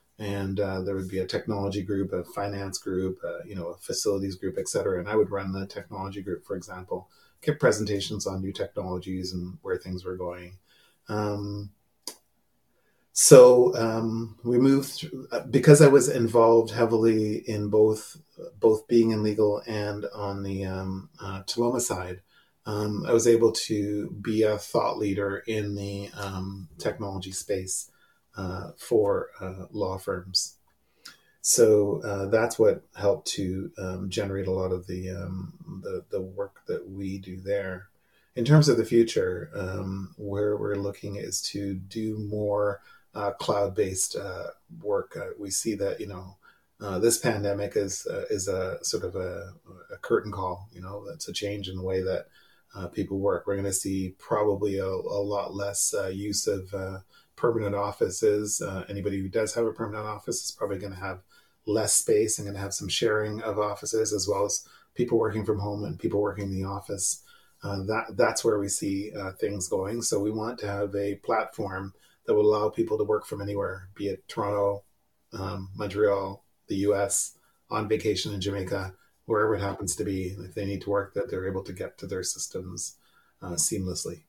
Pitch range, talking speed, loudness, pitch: 95-110 Hz, 180 wpm, -27 LUFS, 100 Hz